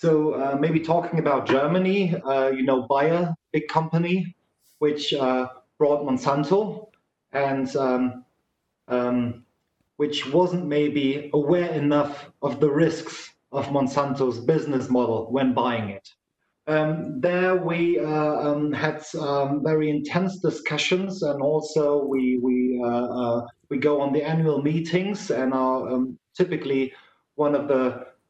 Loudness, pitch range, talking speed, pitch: -24 LUFS, 130-160 Hz, 135 wpm, 145 Hz